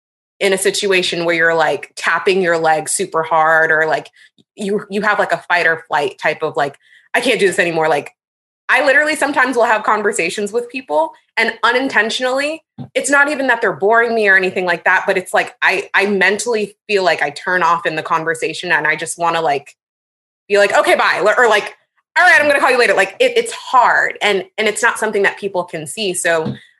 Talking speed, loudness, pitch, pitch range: 220 wpm, -14 LUFS, 200 Hz, 170-230 Hz